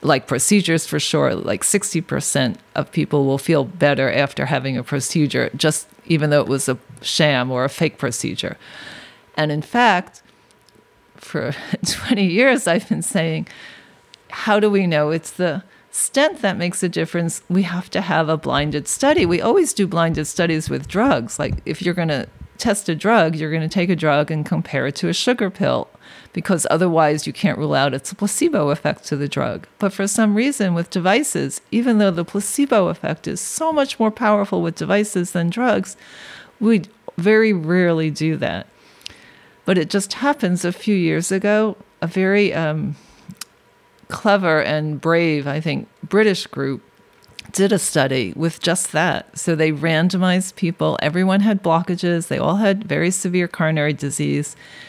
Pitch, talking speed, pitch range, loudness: 175 Hz, 170 wpm, 155-200 Hz, -19 LUFS